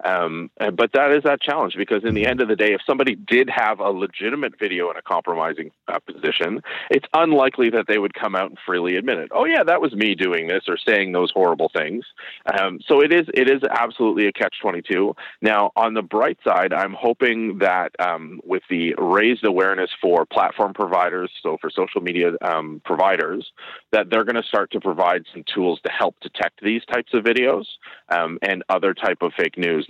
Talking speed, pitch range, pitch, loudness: 205 wpm, 90-115 Hz, 105 Hz, -20 LUFS